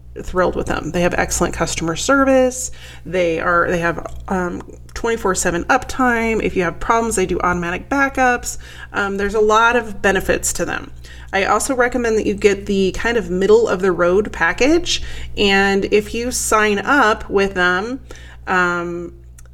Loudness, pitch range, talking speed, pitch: -17 LUFS, 175-230 Hz, 165 wpm, 195 Hz